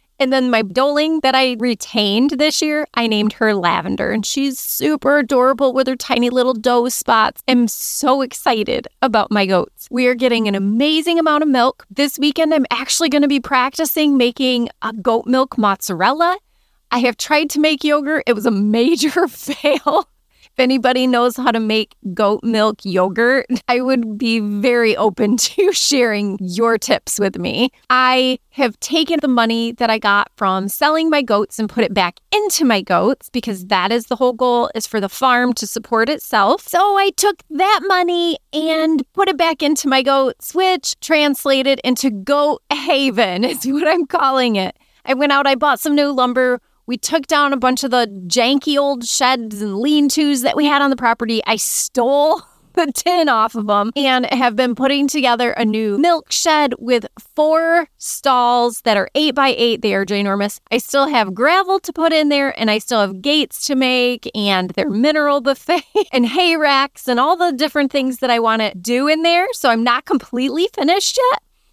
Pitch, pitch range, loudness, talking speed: 255 Hz, 230-295 Hz, -16 LUFS, 190 wpm